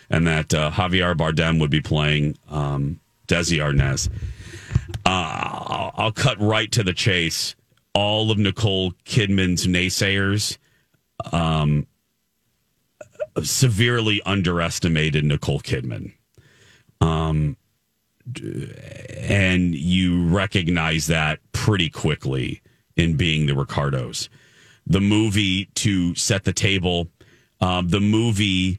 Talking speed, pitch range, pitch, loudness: 100 wpm, 80-105 Hz, 90 Hz, -21 LUFS